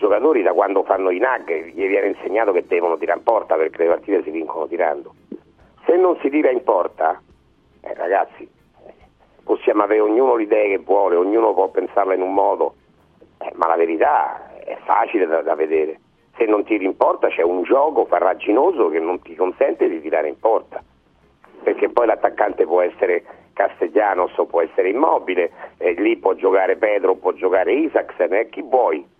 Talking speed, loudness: 180 wpm, -18 LUFS